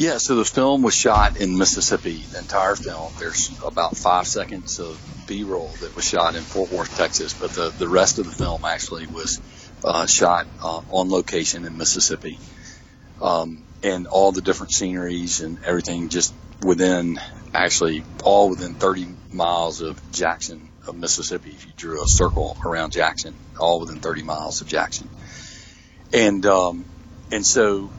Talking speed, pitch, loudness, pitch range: 165 wpm, 90 Hz, -21 LUFS, 85-95 Hz